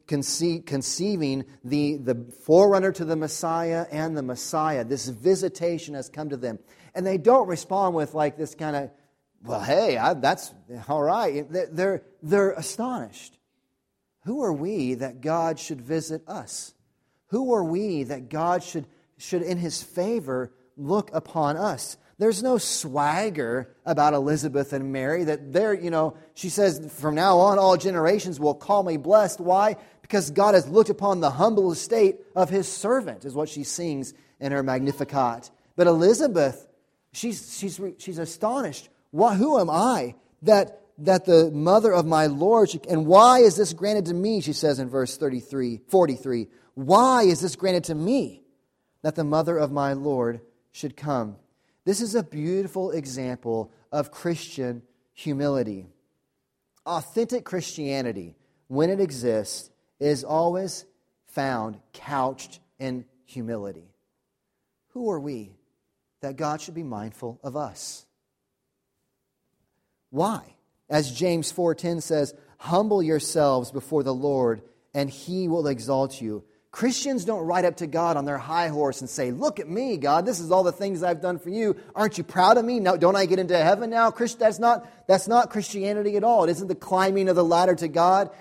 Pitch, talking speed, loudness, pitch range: 160 Hz, 160 wpm, -24 LUFS, 140-190 Hz